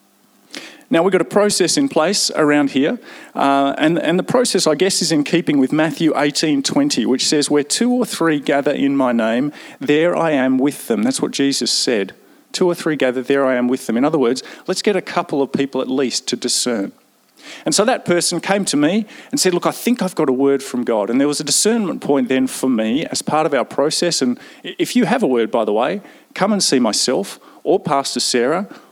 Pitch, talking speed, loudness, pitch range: 155 Hz, 230 wpm, -17 LUFS, 140-195 Hz